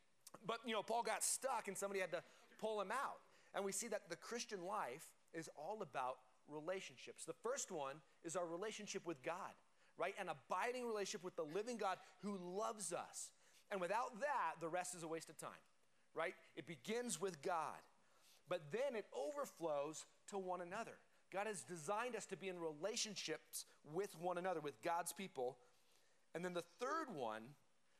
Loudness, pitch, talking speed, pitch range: -47 LUFS, 185 Hz, 180 wpm, 165-210 Hz